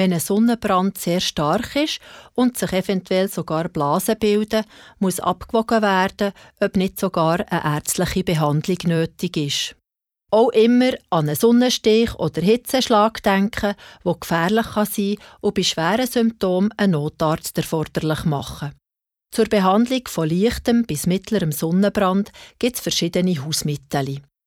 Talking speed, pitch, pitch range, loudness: 135 wpm, 190 Hz, 165-220 Hz, -20 LUFS